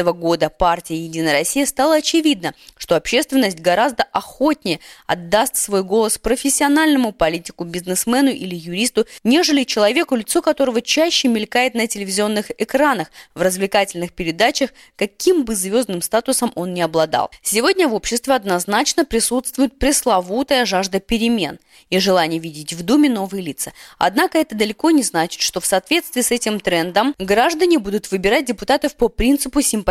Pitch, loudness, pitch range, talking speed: 225 Hz, -17 LUFS, 185-270 Hz, 140 wpm